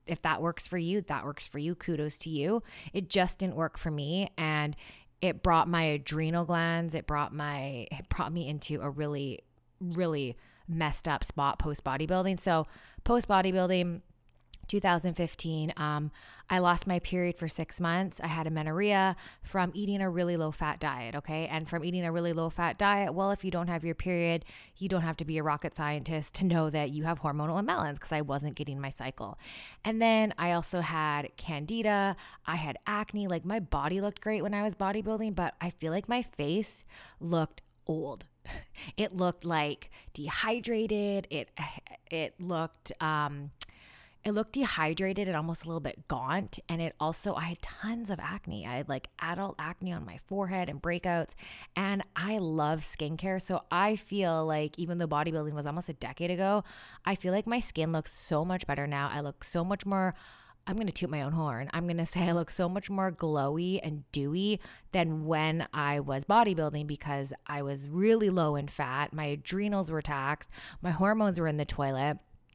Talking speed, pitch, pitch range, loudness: 190 wpm, 165 Hz, 150-190 Hz, -32 LUFS